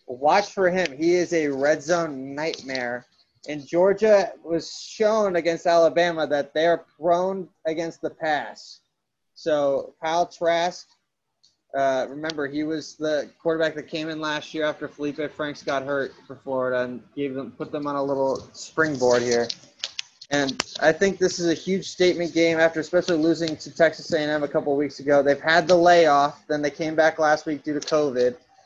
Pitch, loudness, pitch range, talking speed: 155 Hz, -23 LUFS, 145-170 Hz, 180 wpm